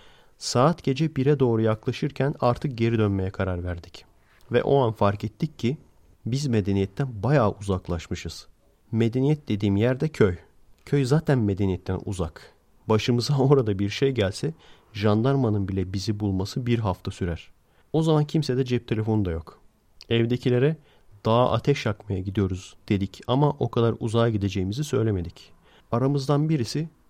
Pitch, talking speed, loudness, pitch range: 115 Hz, 135 wpm, -25 LUFS, 100-135 Hz